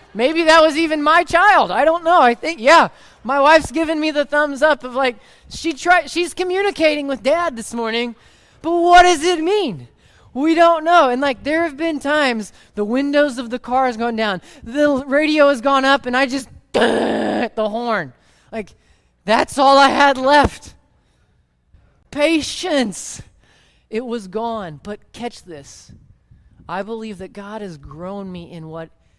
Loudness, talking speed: -16 LUFS, 170 wpm